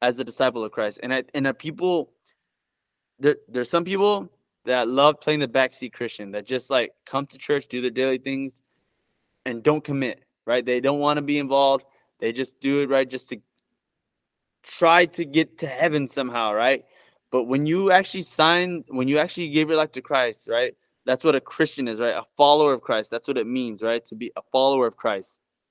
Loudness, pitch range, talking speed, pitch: -23 LUFS, 130-155 Hz, 210 wpm, 135 Hz